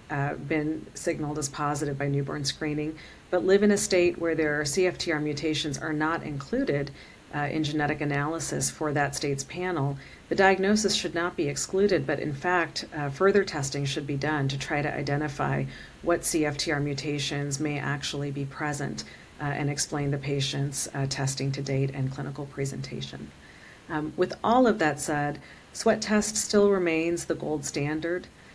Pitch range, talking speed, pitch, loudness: 140-165 Hz, 165 wpm, 150 Hz, -27 LUFS